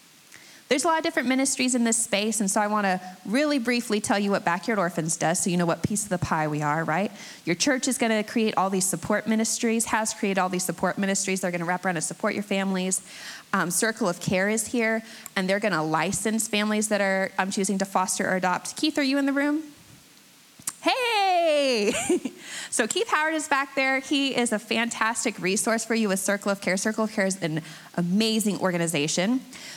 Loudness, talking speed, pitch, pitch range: -25 LUFS, 210 wpm, 210 Hz, 185-240 Hz